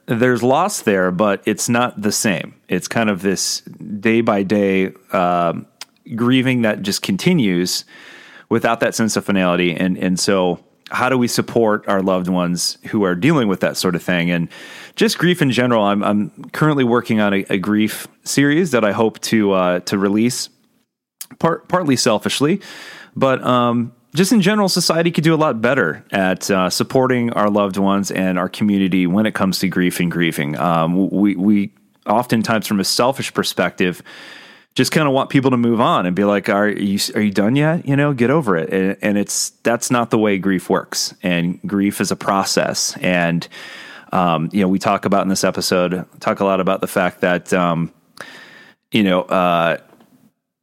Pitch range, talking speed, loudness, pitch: 95-120 Hz, 185 wpm, -17 LUFS, 100 Hz